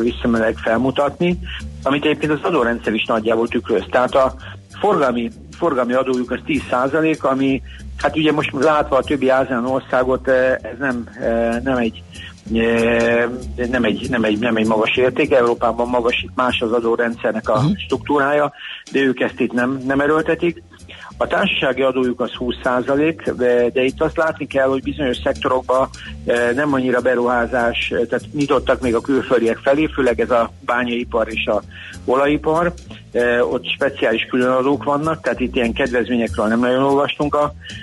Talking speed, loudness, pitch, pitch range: 150 wpm, -18 LUFS, 125 Hz, 115-135 Hz